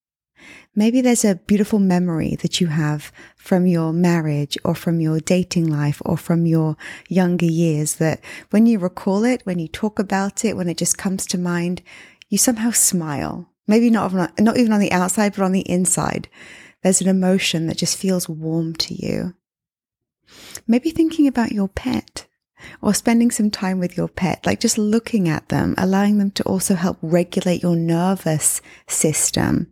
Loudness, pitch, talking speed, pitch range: -19 LUFS, 185 Hz, 175 wpm, 170-210 Hz